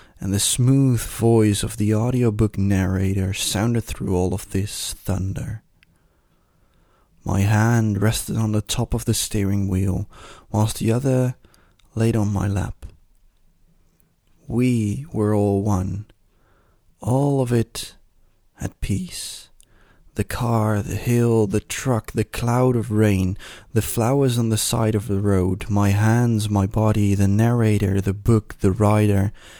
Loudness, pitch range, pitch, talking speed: -21 LUFS, 95-115 Hz, 105 Hz, 140 wpm